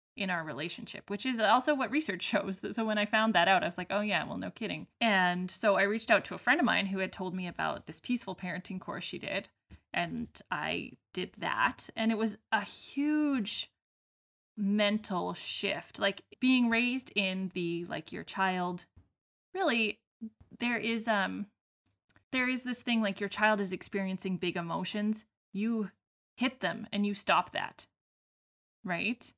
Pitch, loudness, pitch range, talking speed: 205 Hz, -32 LUFS, 190-230 Hz, 175 wpm